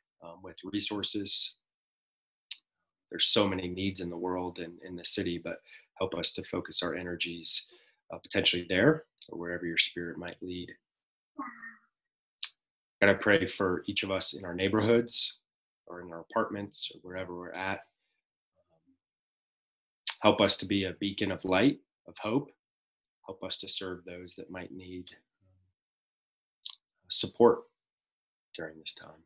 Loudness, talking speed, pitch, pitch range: -30 LUFS, 145 wpm, 95 Hz, 90-100 Hz